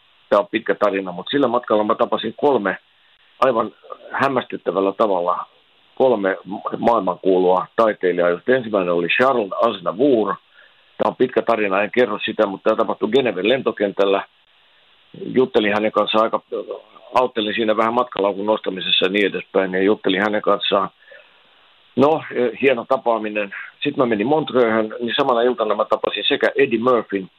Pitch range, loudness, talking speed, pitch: 100-125 Hz, -19 LUFS, 140 wpm, 110 Hz